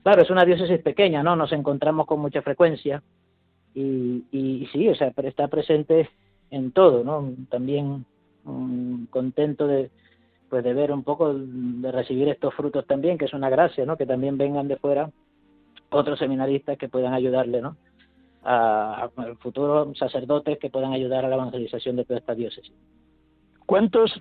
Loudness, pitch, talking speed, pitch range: -23 LUFS, 135 Hz, 160 wpm, 125-145 Hz